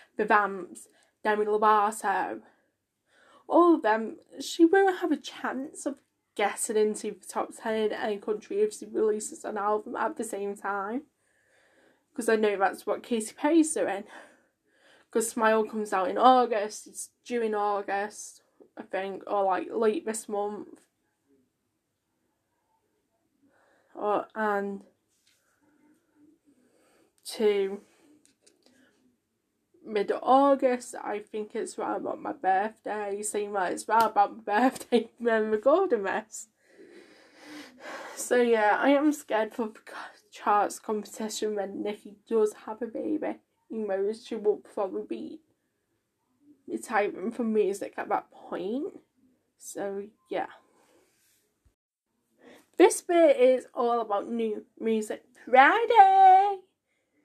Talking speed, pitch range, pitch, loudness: 120 wpm, 210-295 Hz, 230 Hz, -27 LUFS